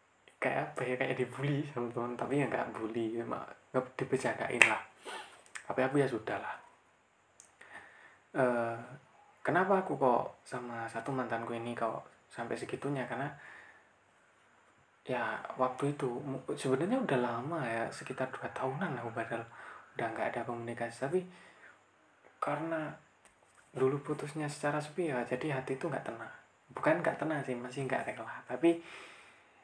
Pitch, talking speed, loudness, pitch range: 130 Hz, 135 wpm, -35 LUFS, 120-145 Hz